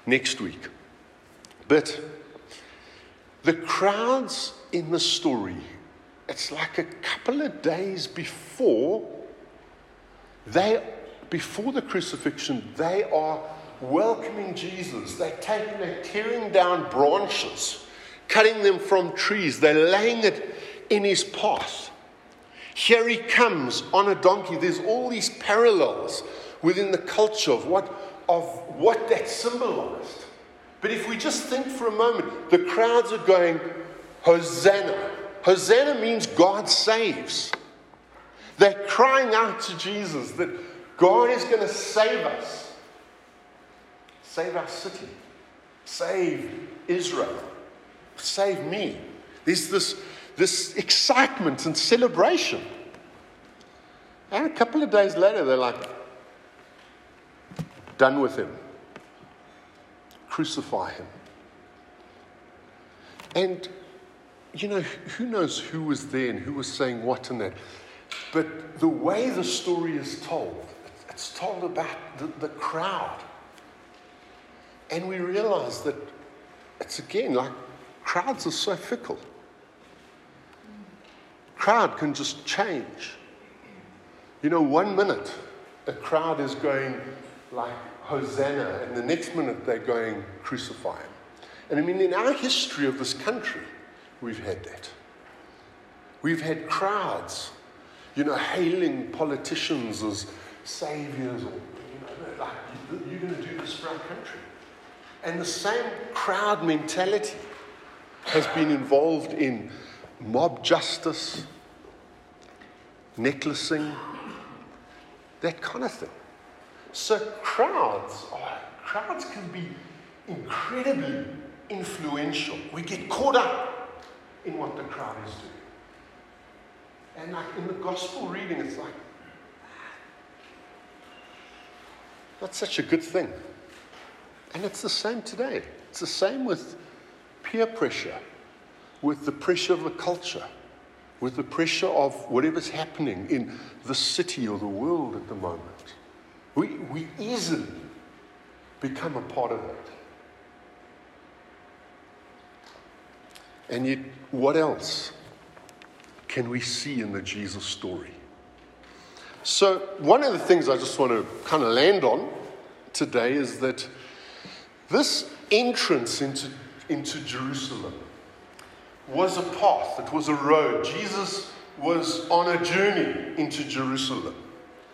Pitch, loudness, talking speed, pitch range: 185 Hz, -25 LUFS, 115 wpm, 155-245 Hz